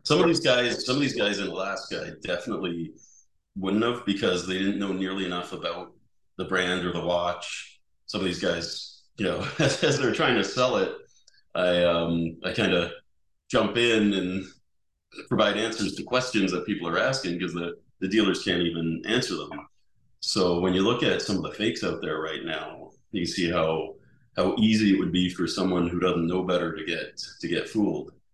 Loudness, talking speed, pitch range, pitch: -26 LUFS, 200 wpm, 85-100 Hz, 90 Hz